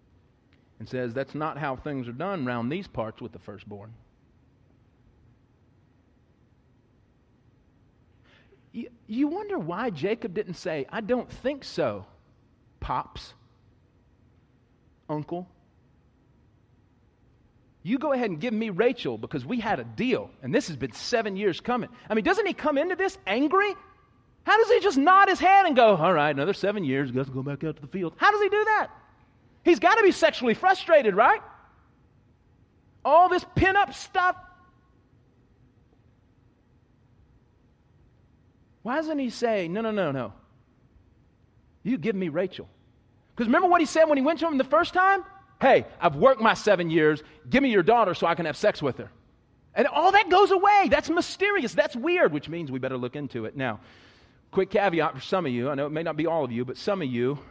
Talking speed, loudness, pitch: 175 wpm, -24 LUFS, 195 Hz